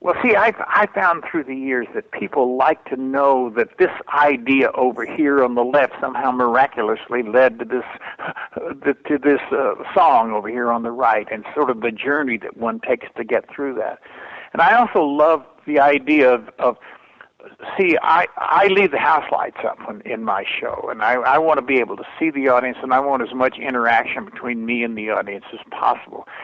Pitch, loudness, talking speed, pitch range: 130 Hz, -18 LUFS, 205 wpm, 120-145 Hz